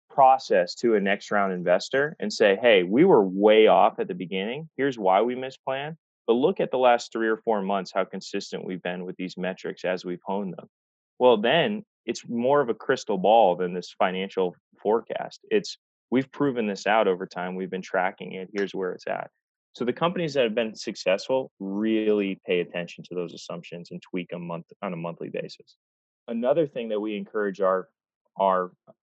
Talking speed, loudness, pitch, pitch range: 200 wpm, -25 LUFS, 100 Hz, 90-125 Hz